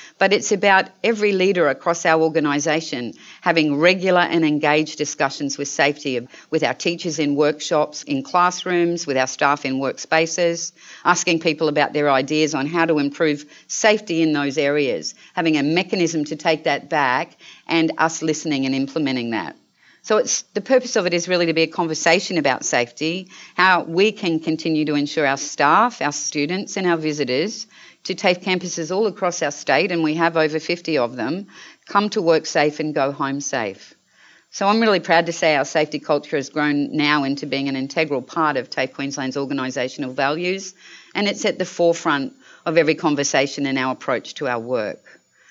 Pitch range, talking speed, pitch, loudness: 145-175 Hz, 180 wpm, 160 Hz, -20 LUFS